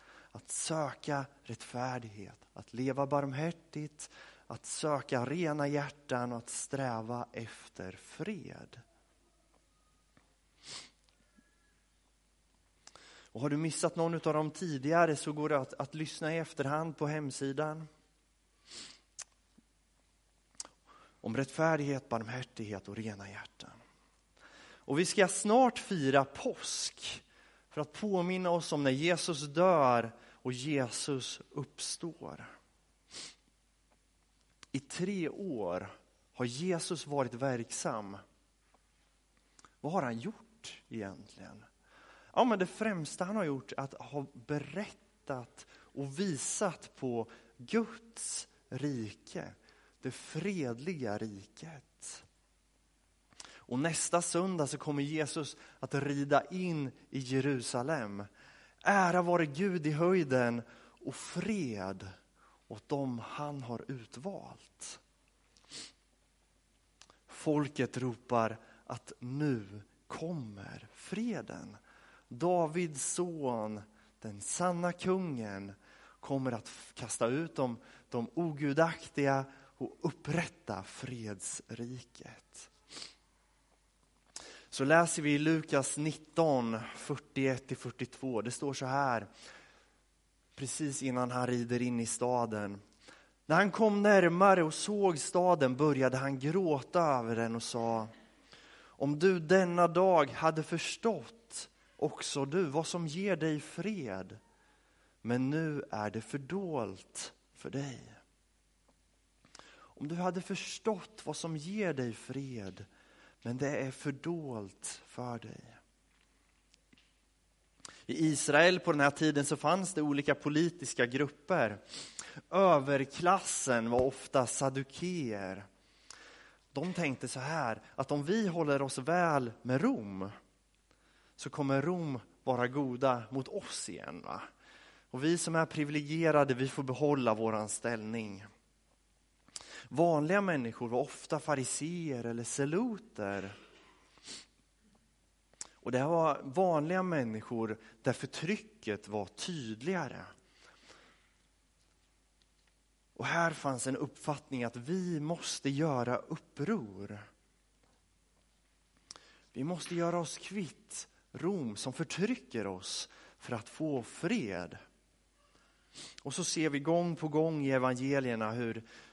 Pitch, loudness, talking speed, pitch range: 140 Hz, -34 LUFS, 105 wpm, 120-165 Hz